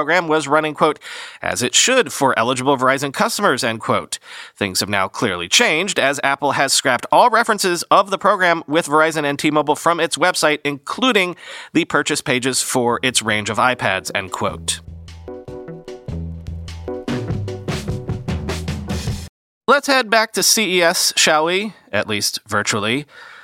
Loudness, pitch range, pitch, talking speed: -17 LUFS, 110-170 Hz, 140 Hz, 145 wpm